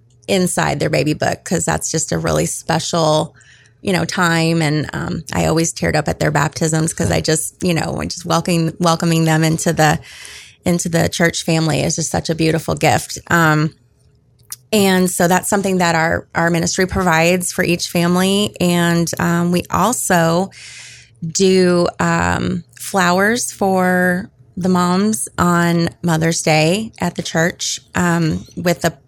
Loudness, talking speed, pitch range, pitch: -16 LUFS, 155 wpm, 160-180 Hz, 170 Hz